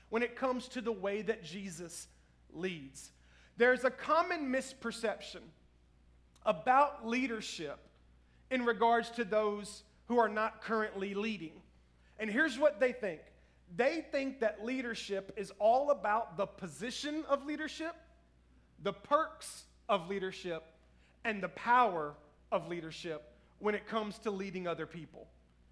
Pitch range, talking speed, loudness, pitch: 160-245 Hz, 130 wpm, -35 LUFS, 210 Hz